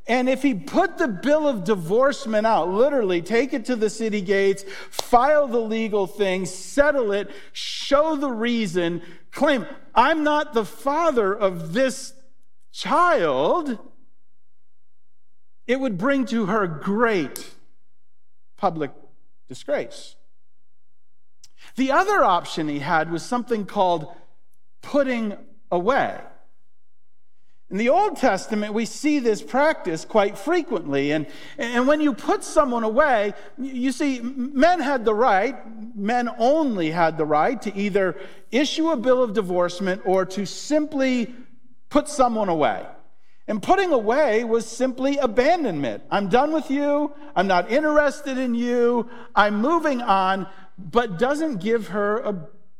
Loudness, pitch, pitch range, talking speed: -22 LUFS, 235 Hz, 195-275 Hz, 130 wpm